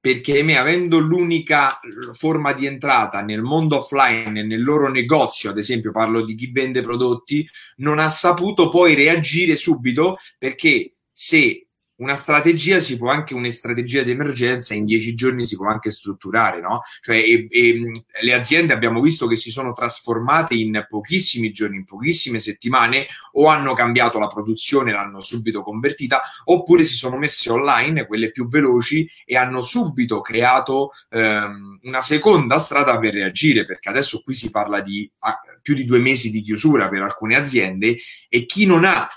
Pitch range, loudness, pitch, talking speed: 115-150 Hz, -18 LUFS, 125 Hz, 165 wpm